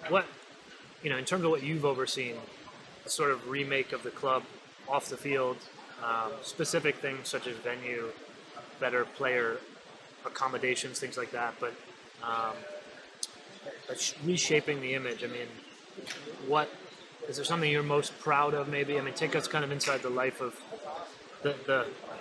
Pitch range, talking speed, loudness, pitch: 125-150 Hz, 160 wpm, -32 LUFS, 140 Hz